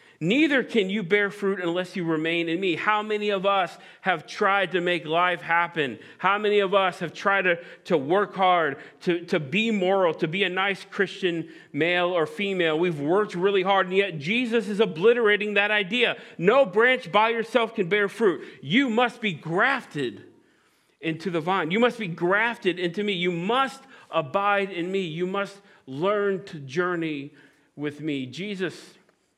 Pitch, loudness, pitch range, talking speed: 195 Hz, -24 LUFS, 175-210 Hz, 175 wpm